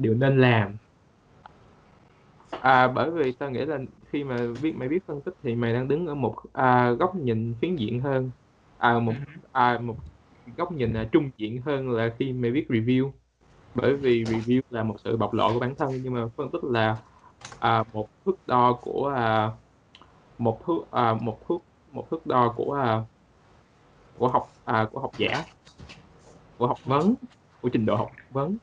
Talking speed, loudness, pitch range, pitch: 185 wpm, -26 LUFS, 110-135 Hz, 120 Hz